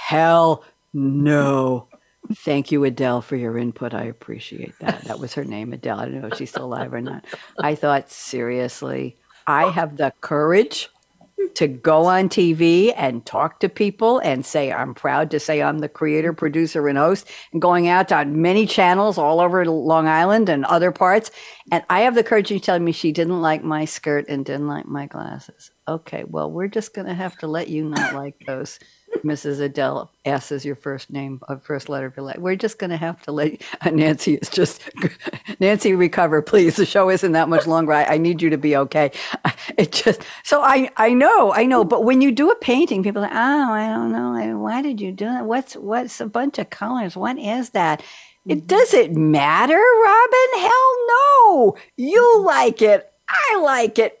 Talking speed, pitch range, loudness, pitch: 205 wpm, 145-220 Hz, -18 LUFS, 165 Hz